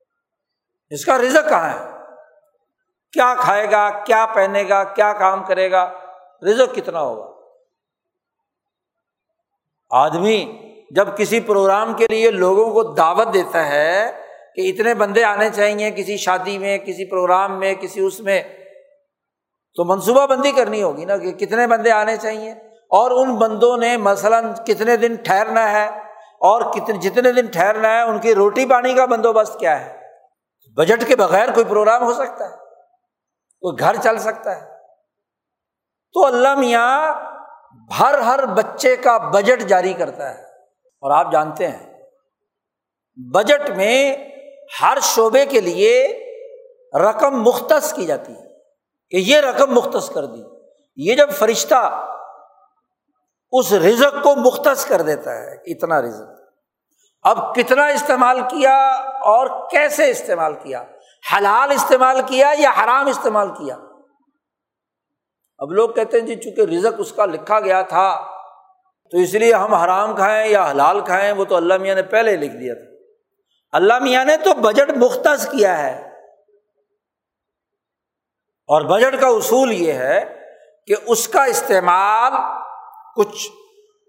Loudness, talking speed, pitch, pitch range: -16 LUFS, 140 wpm, 235 Hz, 205-285 Hz